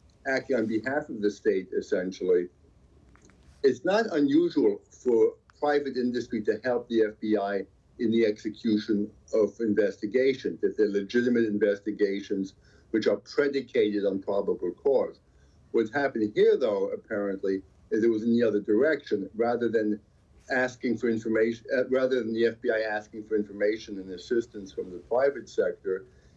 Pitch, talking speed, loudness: 115 Hz, 140 wpm, -27 LUFS